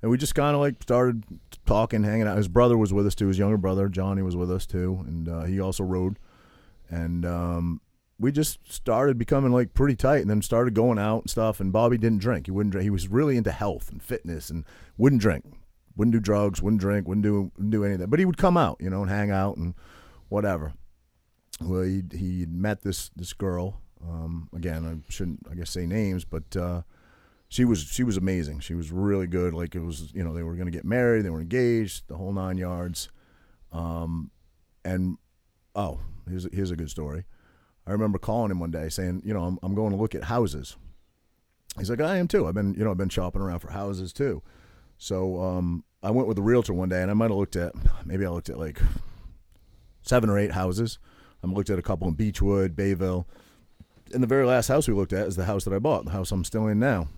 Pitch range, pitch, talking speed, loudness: 85-110 Hz, 95 Hz, 230 wpm, -26 LUFS